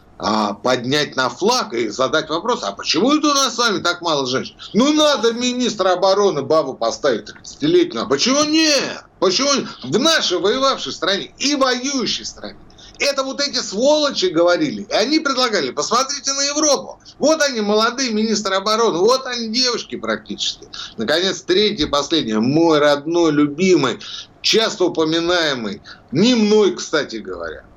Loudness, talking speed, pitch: -17 LUFS, 145 wpm, 215 Hz